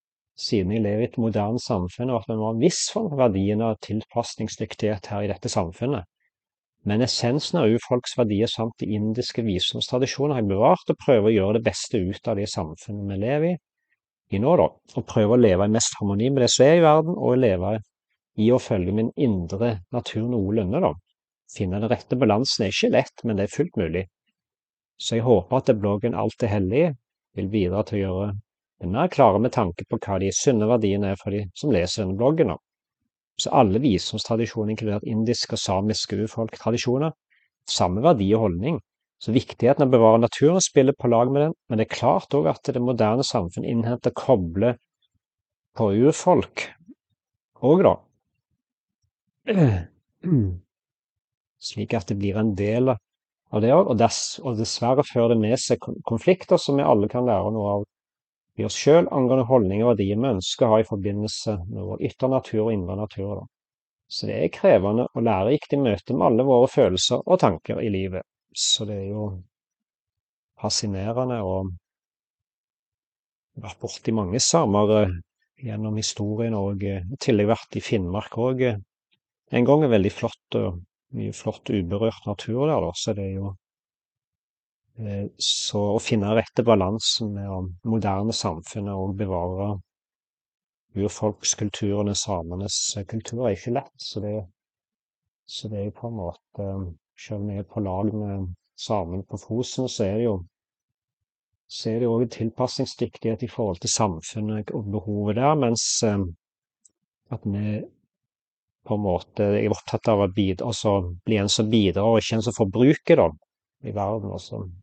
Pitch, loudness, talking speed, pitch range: 110 Hz, -23 LUFS, 170 wpm, 100-120 Hz